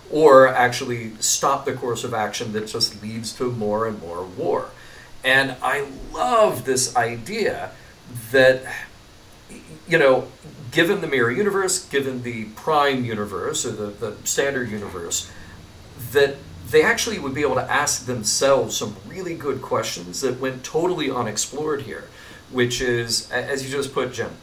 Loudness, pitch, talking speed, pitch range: -21 LUFS, 125 Hz, 150 wpm, 110-135 Hz